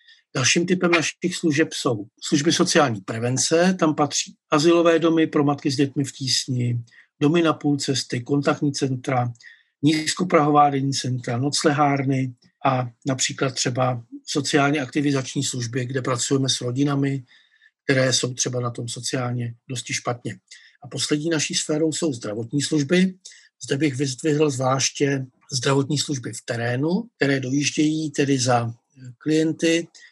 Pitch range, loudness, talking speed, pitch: 130-155 Hz, -22 LUFS, 130 wpm, 145 Hz